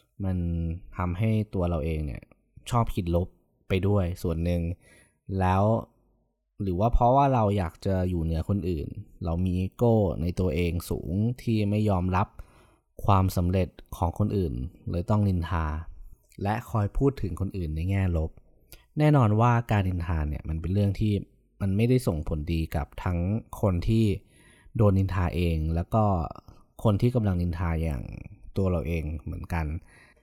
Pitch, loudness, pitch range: 90 Hz, -27 LUFS, 85-105 Hz